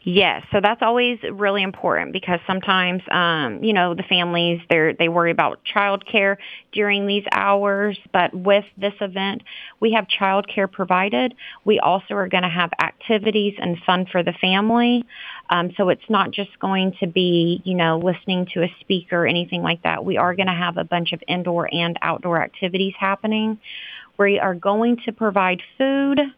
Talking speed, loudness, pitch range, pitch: 180 wpm, -20 LUFS, 175-205 Hz, 195 Hz